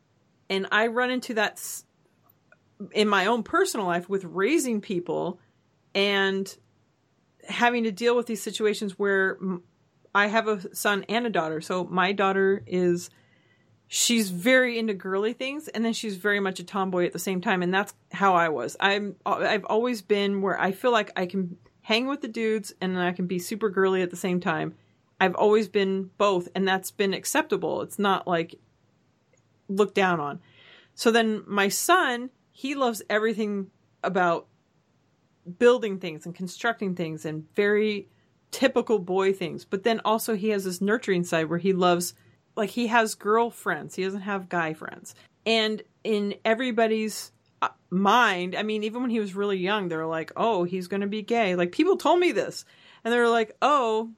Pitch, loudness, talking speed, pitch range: 200 Hz, -25 LUFS, 175 wpm, 180-225 Hz